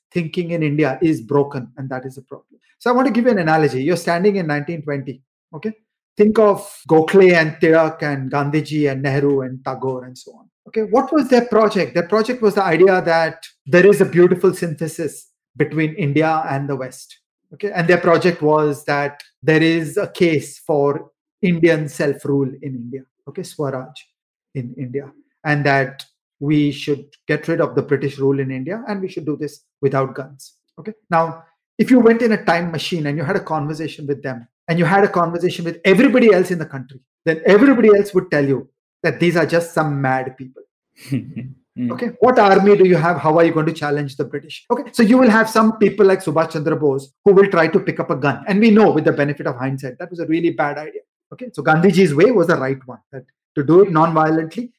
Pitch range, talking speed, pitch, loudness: 145-195 Hz, 215 wpm, 160 Hz, -16 LUFS